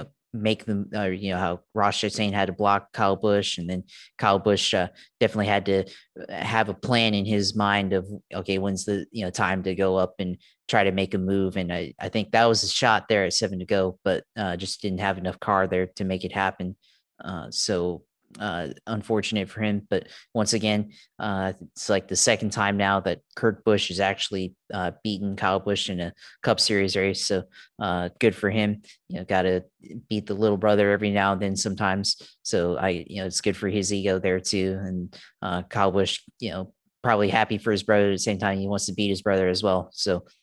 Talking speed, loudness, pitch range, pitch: 225 wpm, -25 LUFS, 95-105 Hz, 100 Hz